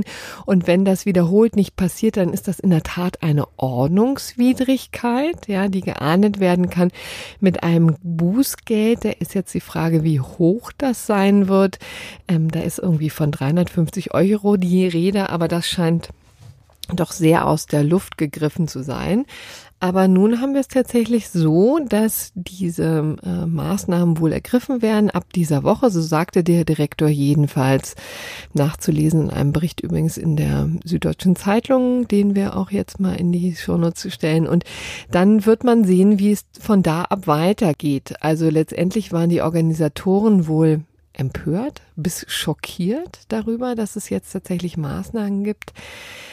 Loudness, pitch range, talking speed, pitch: -19 LUFS, 160-205 Hz, 155 wpm, 180 Hz